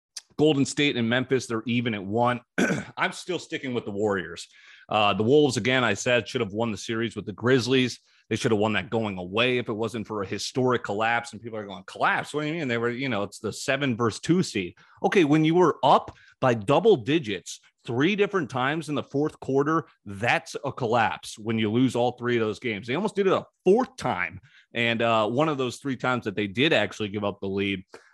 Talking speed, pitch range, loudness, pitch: 230 wpm, 110-135 Hz, -25 LUFS, 120 Hz